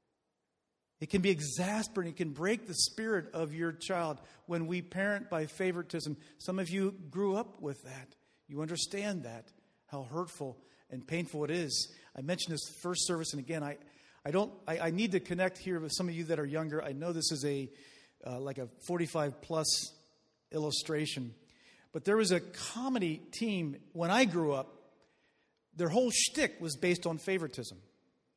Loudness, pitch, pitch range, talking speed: -35 LUFS, 165 Hz, 150-185 Hz, 180 wpm